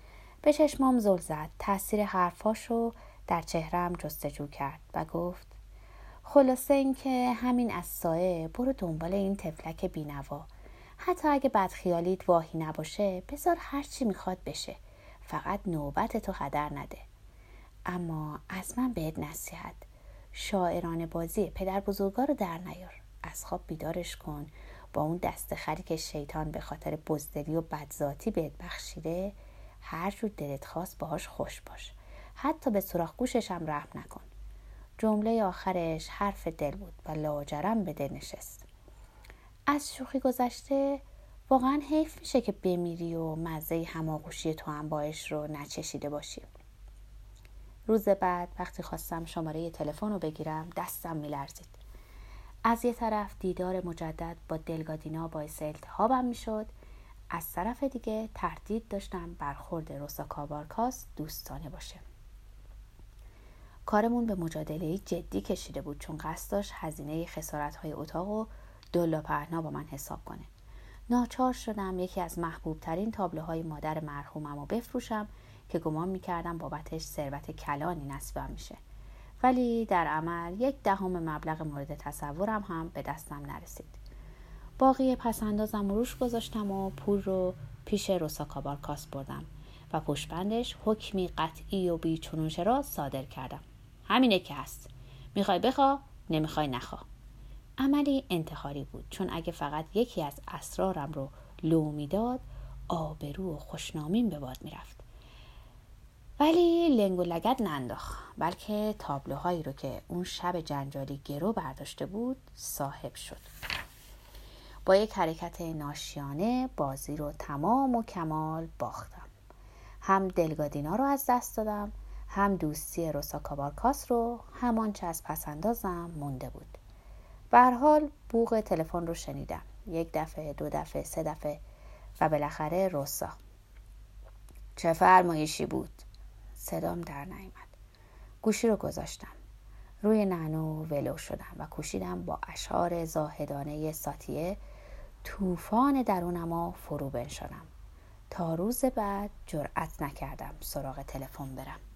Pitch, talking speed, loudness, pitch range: 165 Hz, 130 wpm, -32 LUFS, 145-205 Hz